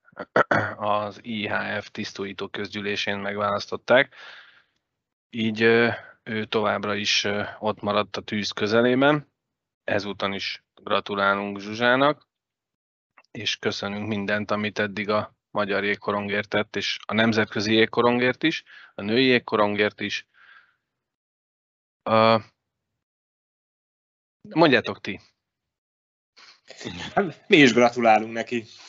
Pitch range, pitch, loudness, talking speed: 100-115 Hz, 105 Hz, -23 LUFS, 85 wpm